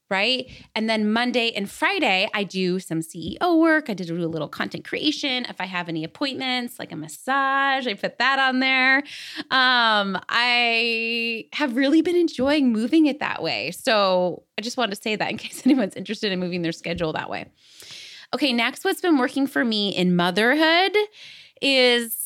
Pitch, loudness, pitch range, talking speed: 235 Hz, -21 LUFS, 190-275 Hz, 180 wpm